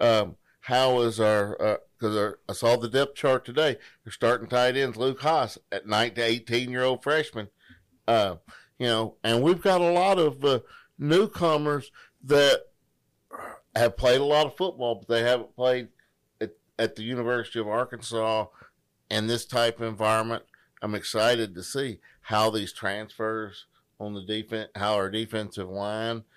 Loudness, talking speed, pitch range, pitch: -26 LUFS, 165 wpm, 110-130 Hz, 115 Hz